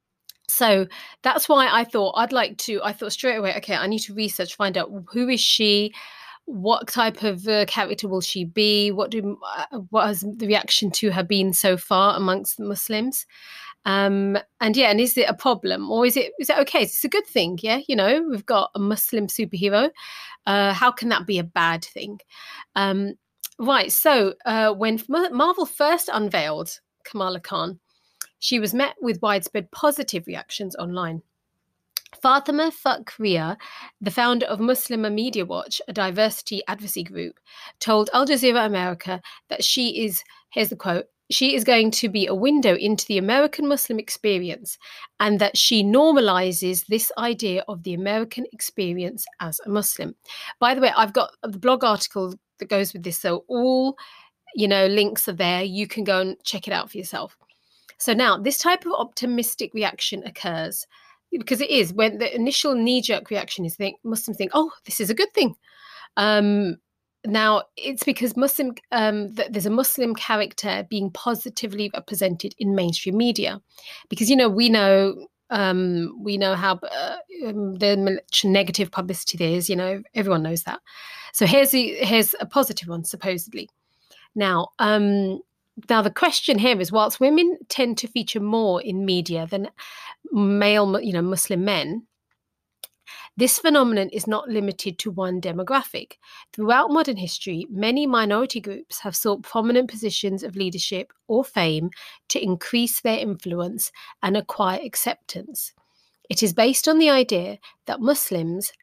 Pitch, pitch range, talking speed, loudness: 215 Hz, 195-250 Hz, 165 wpm, -22 LUFS